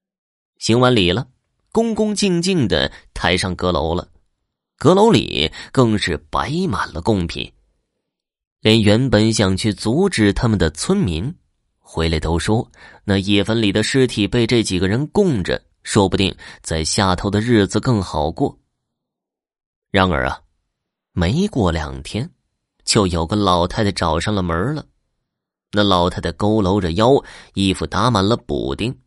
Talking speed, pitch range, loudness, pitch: 205 characters per minute, 90-115 Hz, -18 LUFS, 105 Hz